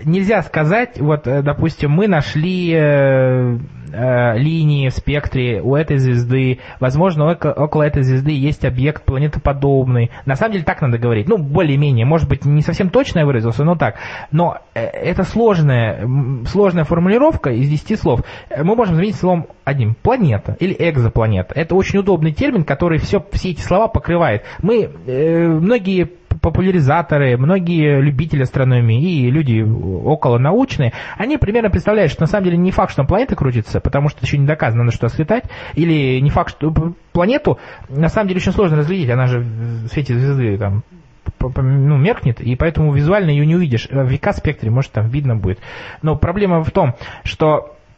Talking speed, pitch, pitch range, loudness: 170 wpm, 145 Hz, 130-170 Hz, -16 LUFS